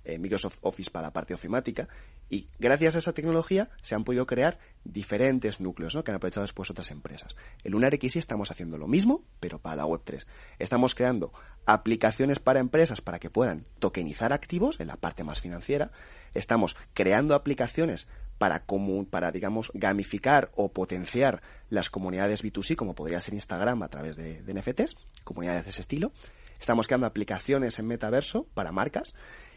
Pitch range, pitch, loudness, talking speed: 95-130 Hz, 105 Hz, -29 LUFS, 170 wpm